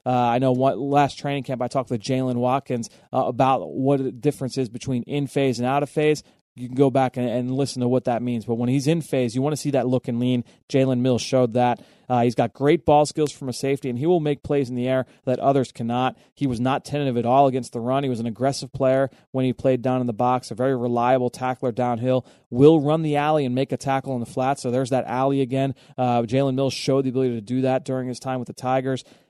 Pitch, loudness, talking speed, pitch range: 130 Hz, -22 LUFS, 270 wpm, 125-140 Hz